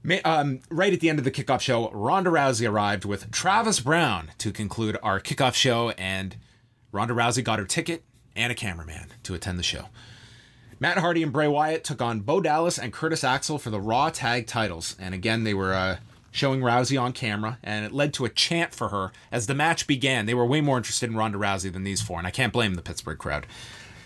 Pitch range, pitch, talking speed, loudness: 105-140 Hz, 120 Hz, 220 wpm, -25 LUFS